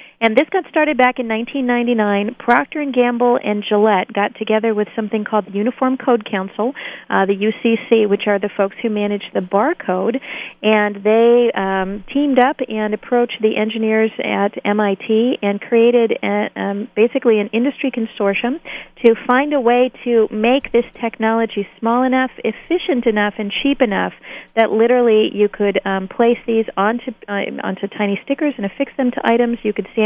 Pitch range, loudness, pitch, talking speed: 210-245 Hz, -17 LUFS, 225 Hz, 170 wpm